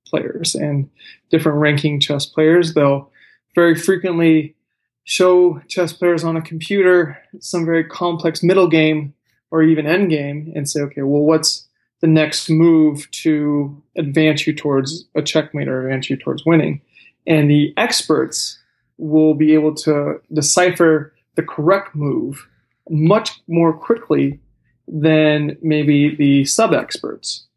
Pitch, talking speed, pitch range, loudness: 155 Hz, 135 wpm, 145-165 Hz, -16 LUFS